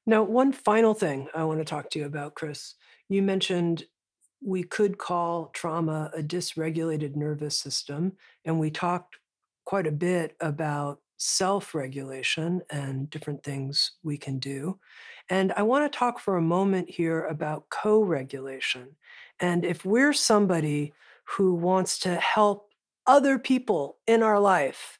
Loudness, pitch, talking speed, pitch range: -26 LUFS, 175 Hz, 150 wpm, 150-200 Hz